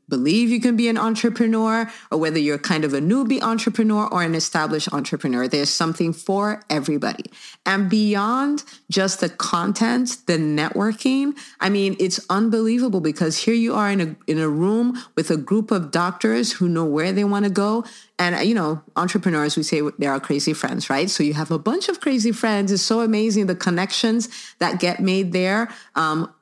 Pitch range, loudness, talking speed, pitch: 160-225 Hz, -21 LUFS, 190 wpm, 195 Hz